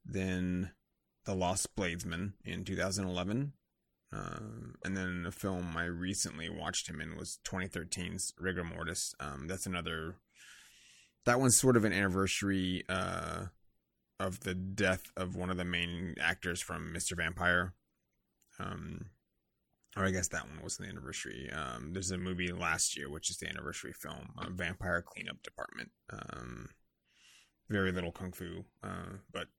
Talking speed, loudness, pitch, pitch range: 150 wpm, -36 LUFS, 90 Hz, 85-95 Hz